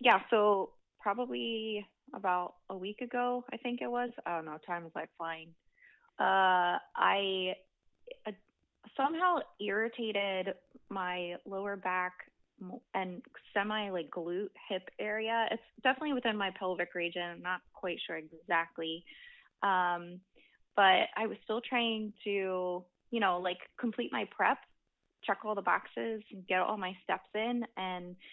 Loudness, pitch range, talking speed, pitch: -34 LUFS, 180-225 Hz, 140 wpm, 195 Hz